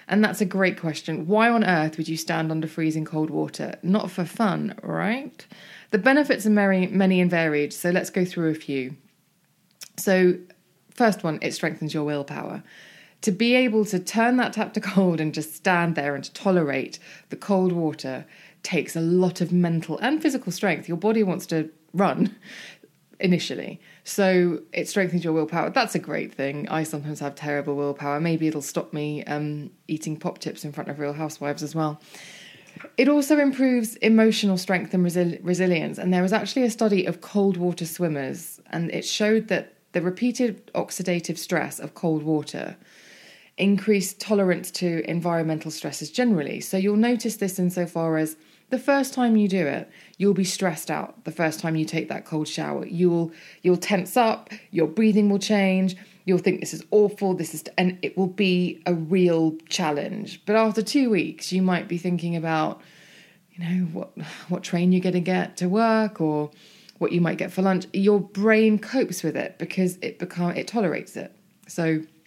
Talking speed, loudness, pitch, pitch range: 180 wpm, -24 LUFS, 180 Hz, 160-200 Hz